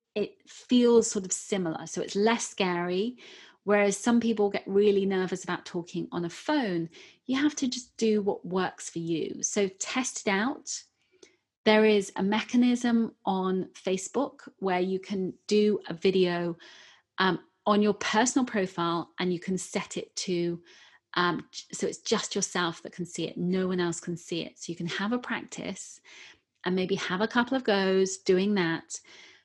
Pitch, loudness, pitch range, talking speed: 200 Hz, -28 LUFS, 180-230 Hz, 175 wpm